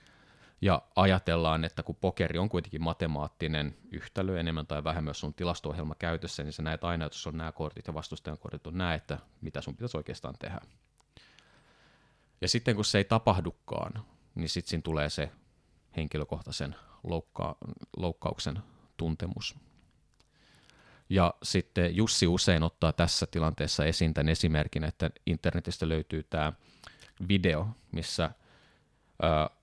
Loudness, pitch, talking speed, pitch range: -32 LUFS, 80 Hz, 140 wpm, 75-90 Hz